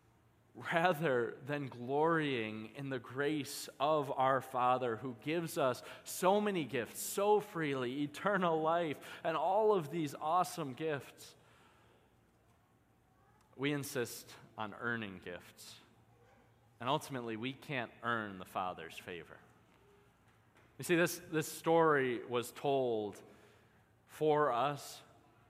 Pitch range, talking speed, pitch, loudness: 115-155 Hz, 110 wpm, 135 Hz, -36 LUFS